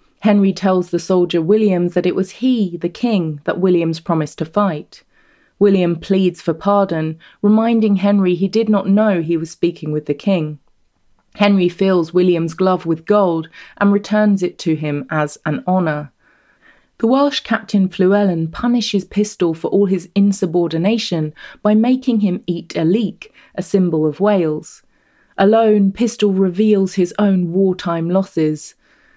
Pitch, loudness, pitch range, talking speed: 185 Hz, -16 LUFS, 170-205 Hz, 150 wpm